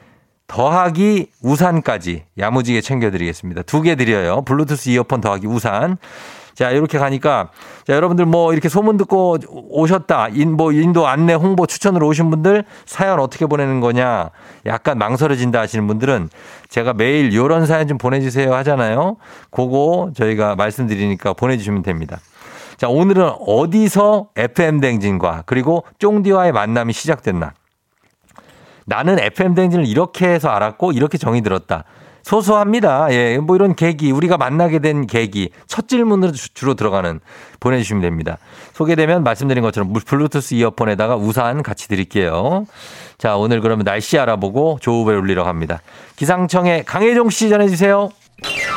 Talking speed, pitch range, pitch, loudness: 350 characters per minute, 110-175 Hz, 140 Hz, -16 LUFS